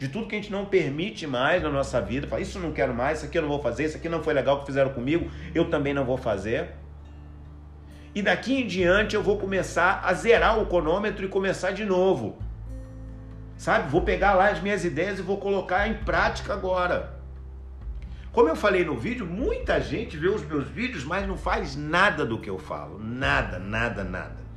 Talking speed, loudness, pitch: 210 wpm, -25 LUFS, 150 Hz